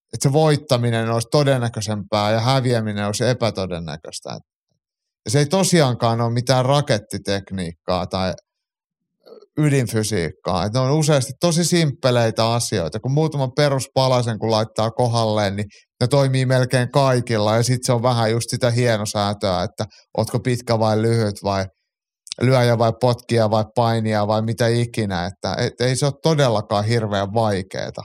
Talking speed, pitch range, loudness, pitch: 140 wpm, 105-130 Hz, -19 LUFS, 115 Hz